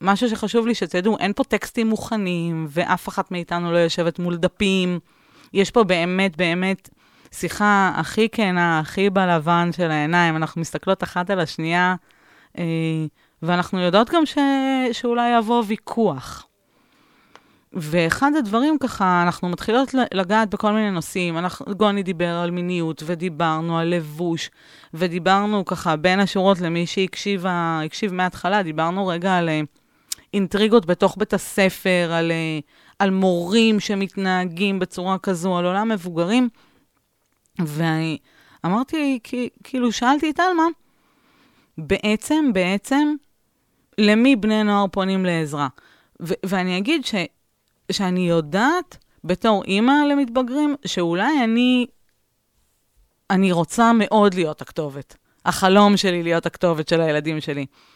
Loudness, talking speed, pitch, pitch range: -20 LUFS, 120 wpm, 190 Hz, 170-220 Hz